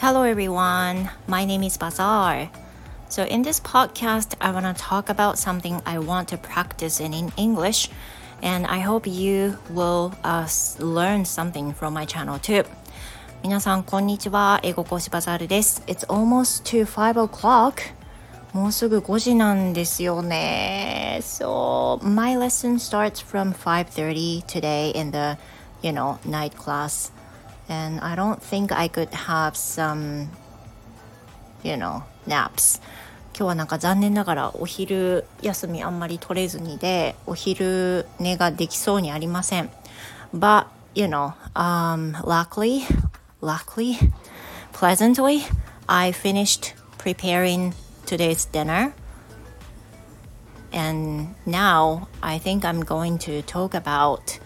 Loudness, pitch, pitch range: -23 LUFS, 180 Hz, 160-200 Hz